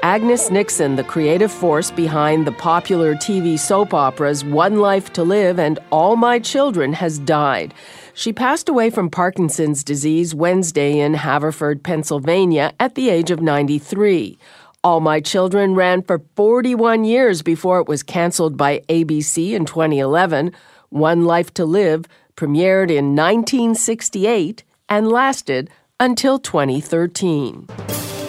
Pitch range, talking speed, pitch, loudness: 150-200 Hz, 130 wpm, 170 Hz, -17 LUFS